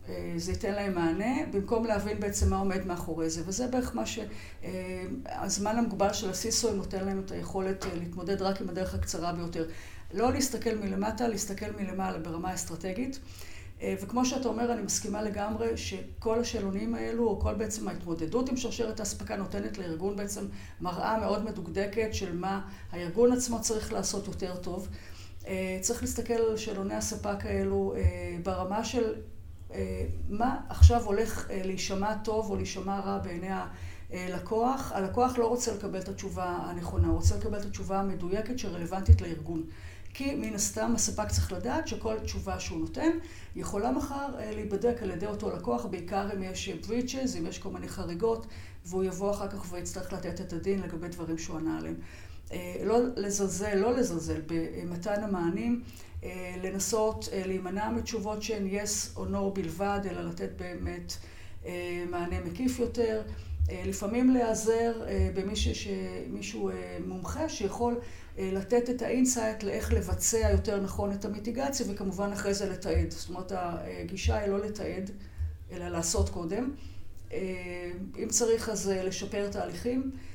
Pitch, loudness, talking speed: 195 Hz, -32 LUFS, 140 wpm